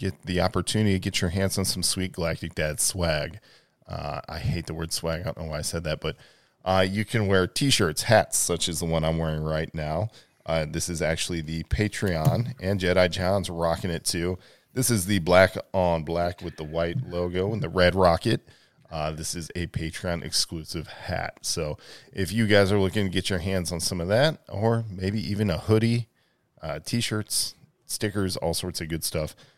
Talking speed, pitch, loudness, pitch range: 210 wpm, 90 Hz, -26 LUFS, 85-100 Hz